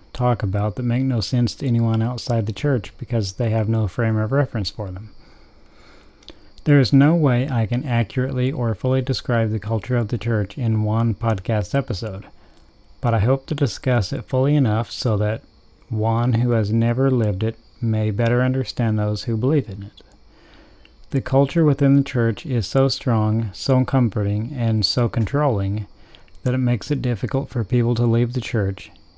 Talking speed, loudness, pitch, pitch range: 180 wpm, -21 LUFS, 115 Hz, 110-130 Hz